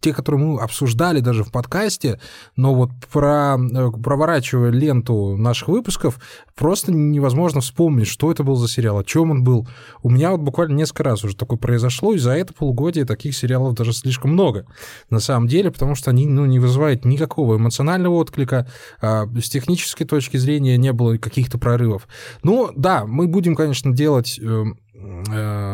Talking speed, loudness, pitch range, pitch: 170 wpm, -18 LUFS, 120-150 Hz, 130 Hz